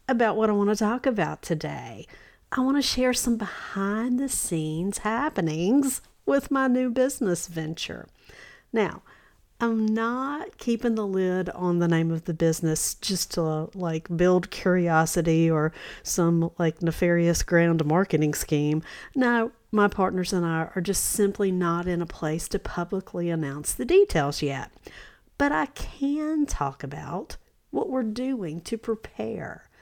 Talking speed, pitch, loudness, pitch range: 145 wpm, 185 Hz, -25 LUFS, 165-235 Hz